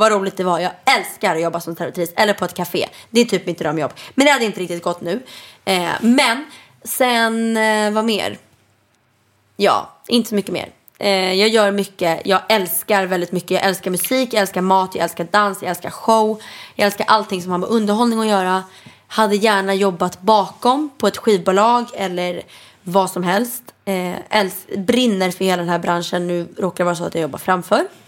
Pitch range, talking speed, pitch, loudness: 180-220 Hz, 195 wpm, 195 Hz, -18 LUFS